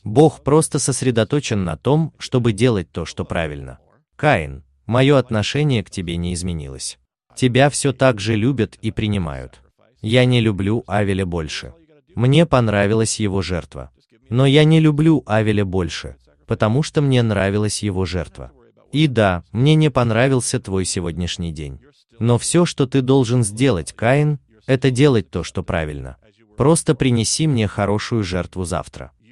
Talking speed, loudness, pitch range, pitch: 145 wpm, -18 LUFS, 90-135 Hz, 110 Hz